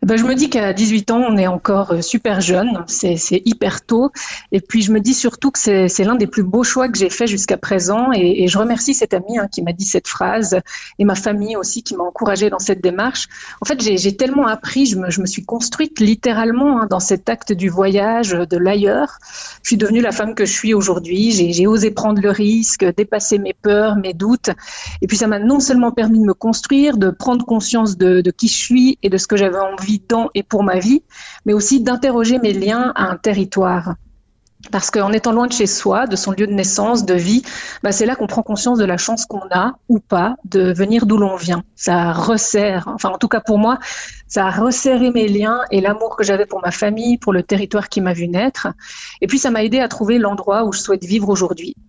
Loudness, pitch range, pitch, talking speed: -16 LUFS, 195-235 Hz, 210 Hz, 240 wpm